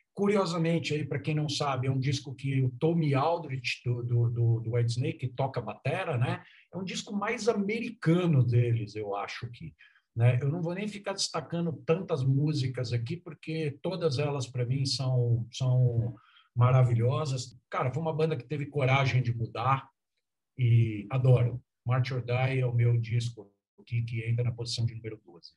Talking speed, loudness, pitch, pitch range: 175 wpm, -29 LUFS, 130 Hz, 120-155 Hz